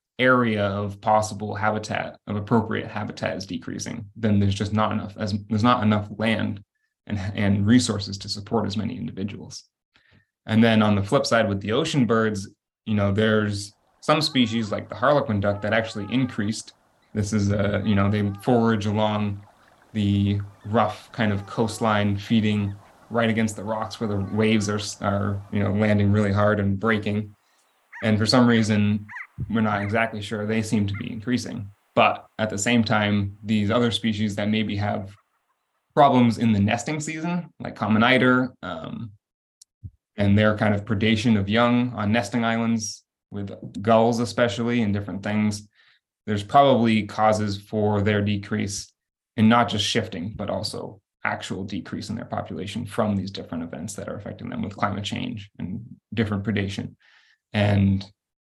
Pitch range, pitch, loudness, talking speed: 105-115 Hz, 105 Hz, -23 LUFS, 165 wpm